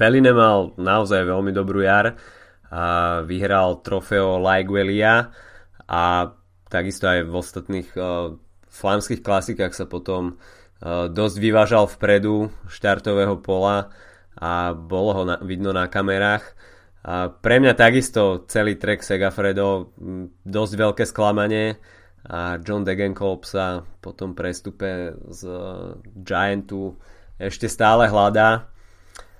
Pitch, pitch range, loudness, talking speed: 95 Hz, 90-105 Hz, -20 LUFS, 110 wpm